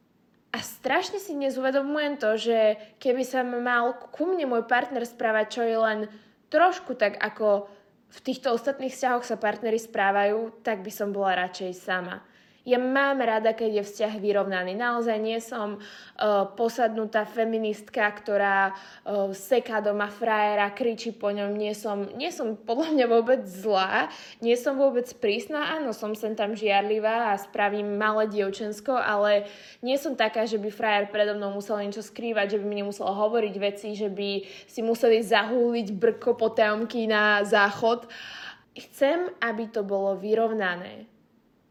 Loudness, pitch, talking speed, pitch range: -26 LUFS, 220 Hz, 150 wpm, 205-240 Hz